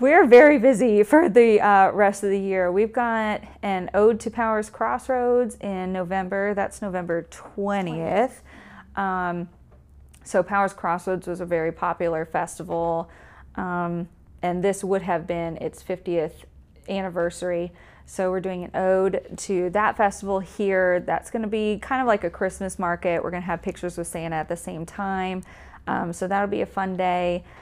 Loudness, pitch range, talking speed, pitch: -23 LUFS, 175-205 Hz, 165 wpm, 190 Hz